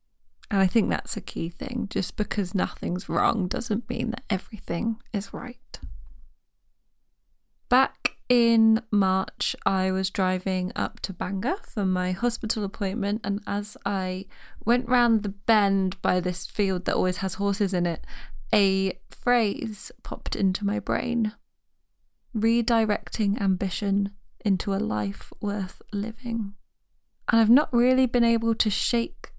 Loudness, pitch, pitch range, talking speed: -26 LUFS, 205 Hz, 190-230 Hz, 135 wpm